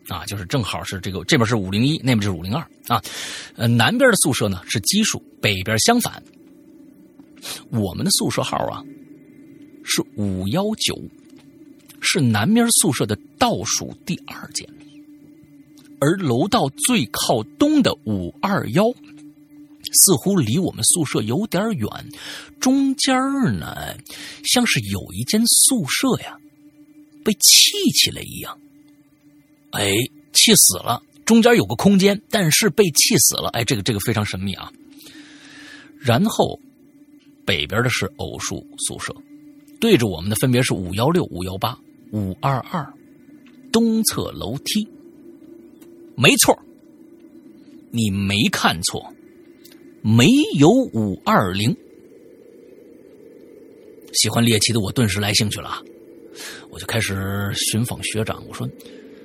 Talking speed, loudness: 185 characters per minute, -18 LUFS